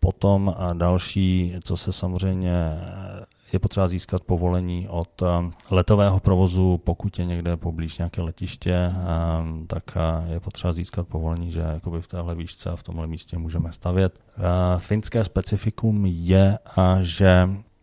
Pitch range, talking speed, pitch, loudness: 85-95 Hz, 130 wpm, 90 Hz, -23 LUFS